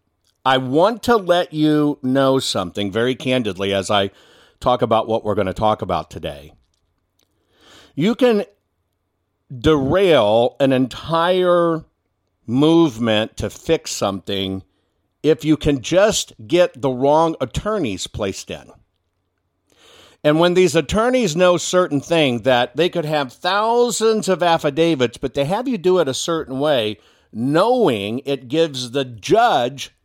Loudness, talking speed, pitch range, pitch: -18 LUFS, 135 wpm, 100-165 Hz, 130 Hz